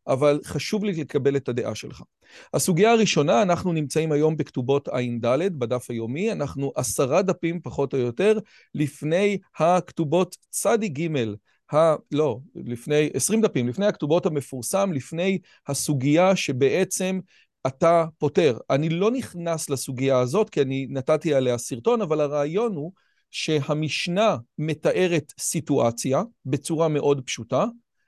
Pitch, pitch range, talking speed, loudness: 155 Hz, 135-185 Hz, 125 wpm, -23 LUFS